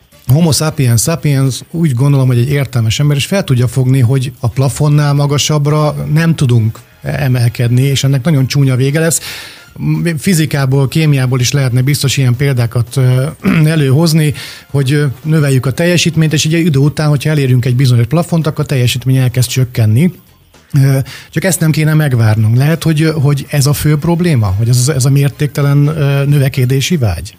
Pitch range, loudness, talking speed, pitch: 130-155 Hz, -11 LUFS, 155 wpm, 140 Hz